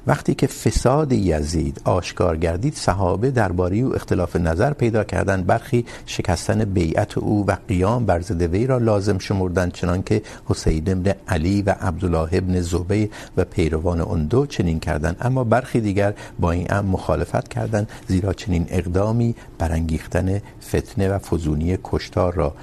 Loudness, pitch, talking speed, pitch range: -21 LUFS, 95 Hz, 150 wpm, 85-110 Hz